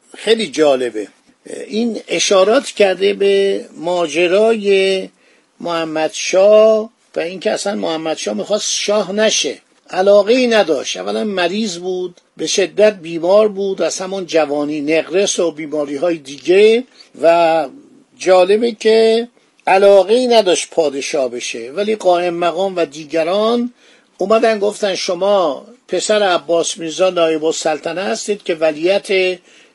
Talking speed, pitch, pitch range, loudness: 120 wpm, 190 Hz, 165-215 Hz, -15 LUFS